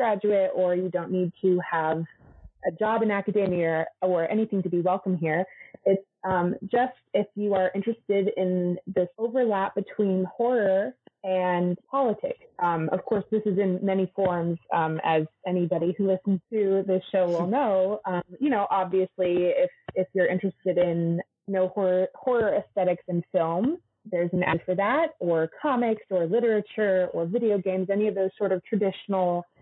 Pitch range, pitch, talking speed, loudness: 180-205 Hz, 190 Hz, 170 wpm, -26 LUFS